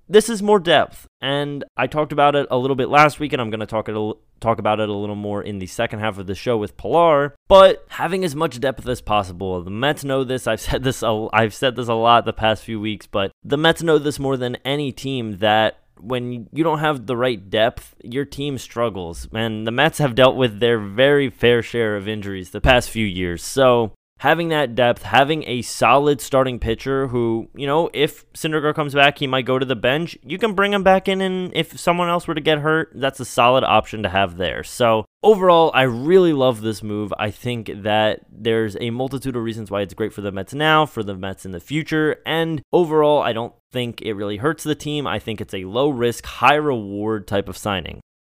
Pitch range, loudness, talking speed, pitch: 110-145 Hz, -19 LUFS, 235 wpm, 125 Hz